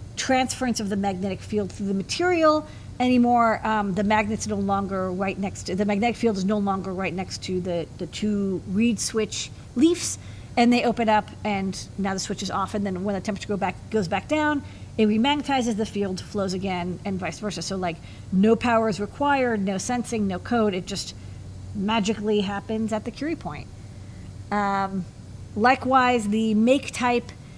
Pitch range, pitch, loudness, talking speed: 190-230 Hz, 205 Hz, -24 LUFS, 185 wpm